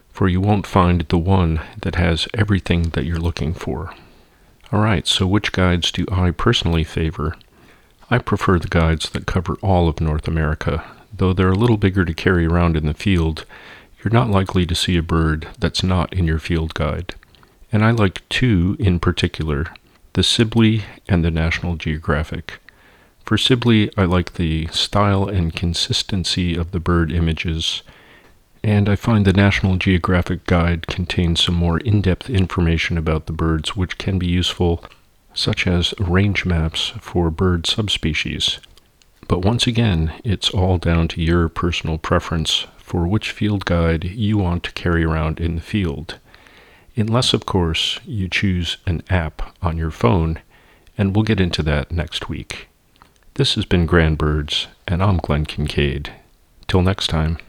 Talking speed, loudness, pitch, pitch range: 165 wpm, -19 LUFS, 90 Hz, 80-95 Hz